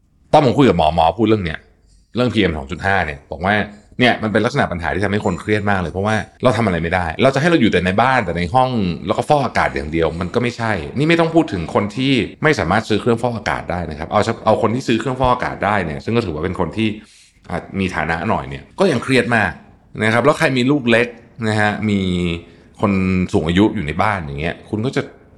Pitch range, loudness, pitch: 85-115 Hz, -17 LUFS, 105 Hz